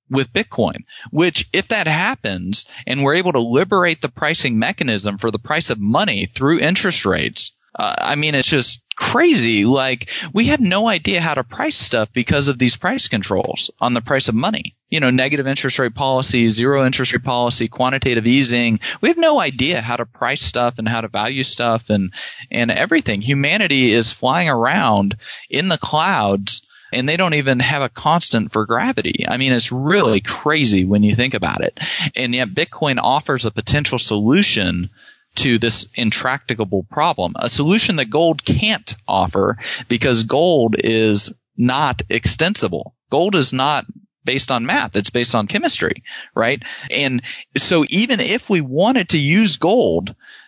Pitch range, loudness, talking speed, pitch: 115-155 Hz, -16 LUFS, 170 wpm, 130 Hz